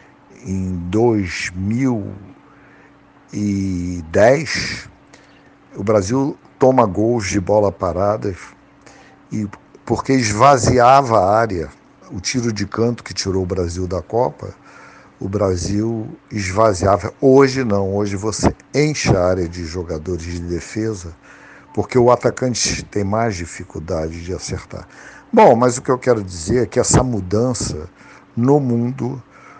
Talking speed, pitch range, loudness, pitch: 120 wpm, 95-125 Hz, -17 LUFS, 105 Hz